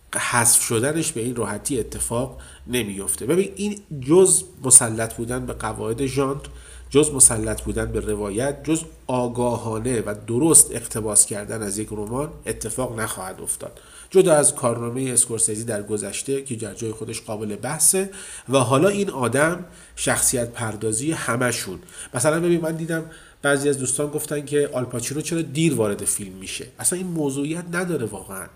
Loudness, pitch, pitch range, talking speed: -21 LUFS, 125 Hz, 110-150 Hz, 150 wpm